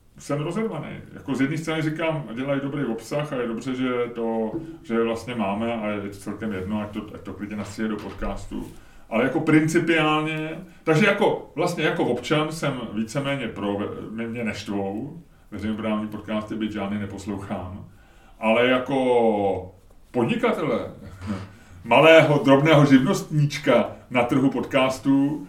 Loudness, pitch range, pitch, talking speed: -23 LUFS, 105-150 Hz, 120 Hz, 135 wpm